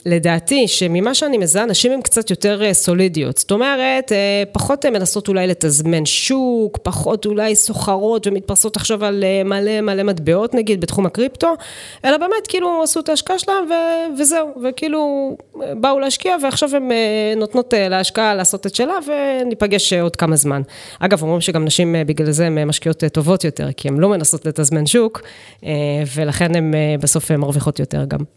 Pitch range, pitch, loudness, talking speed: 165-255 Hz, 200 Hz, -16 LUFS, 155 wpm